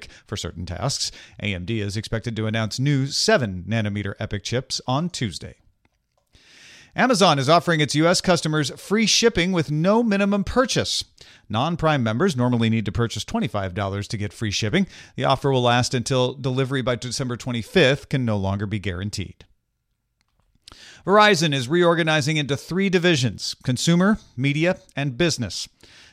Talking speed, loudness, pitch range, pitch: 145 wpm, -21 LUFS, 110-165 Hz, 130 Hz